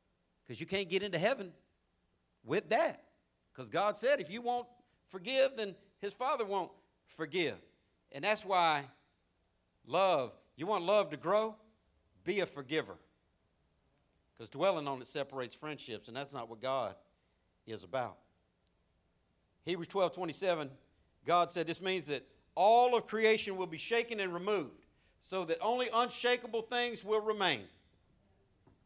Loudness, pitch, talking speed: -34 LUFS, 170 Hz, 140 wpm